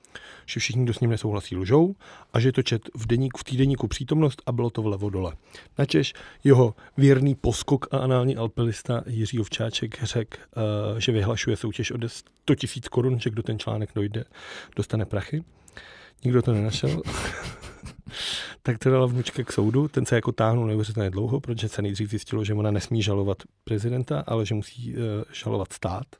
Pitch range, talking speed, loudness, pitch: 110-125 Hz, 175 wpm, -25 LUFS, 115 Hz